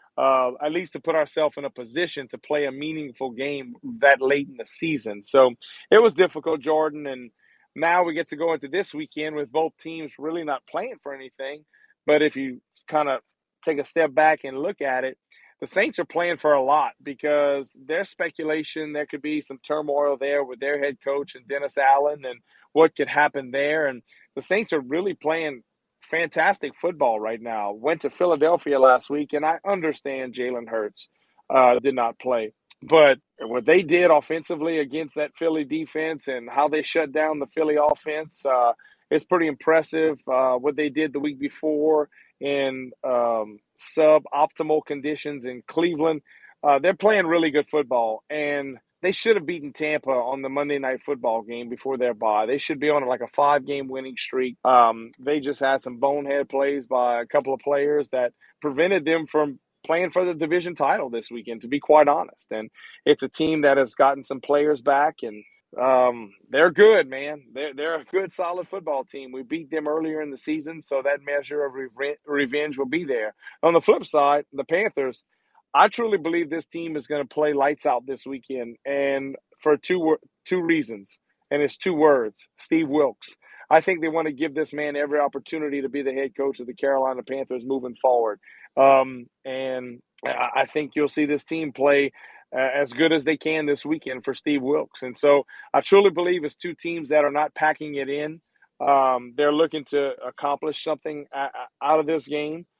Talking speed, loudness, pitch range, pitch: 195 wpm, -23 LUFS, 135-155 Hz, 145 Hz